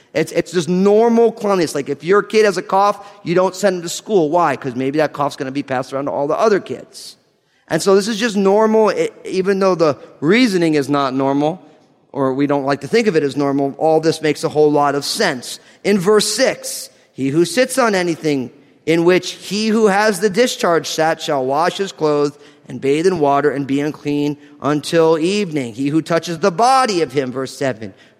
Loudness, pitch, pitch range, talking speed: -16 LUFS, 160 Hz, 145-200 Hz, 220 wpm